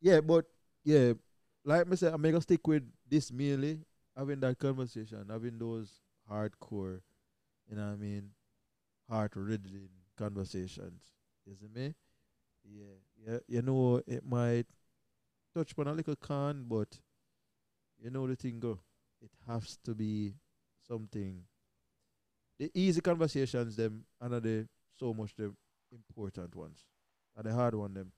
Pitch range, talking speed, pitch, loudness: 105-135 Hz, 145 wpm, 115 Hz, -35 LUFS